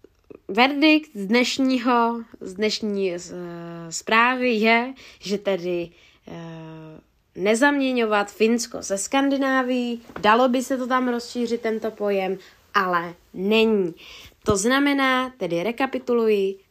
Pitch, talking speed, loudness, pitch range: 225 Hz, 110 wpm, -22 LUFS, 195-255 Hz